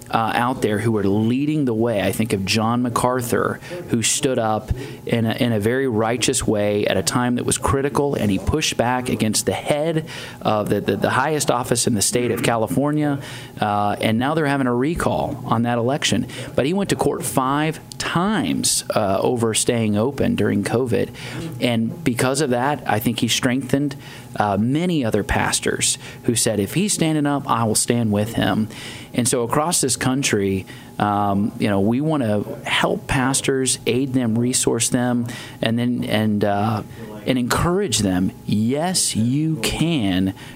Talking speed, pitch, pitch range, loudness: 180 wpm, 125 Hz, 110-140 Hz, -20 LUFS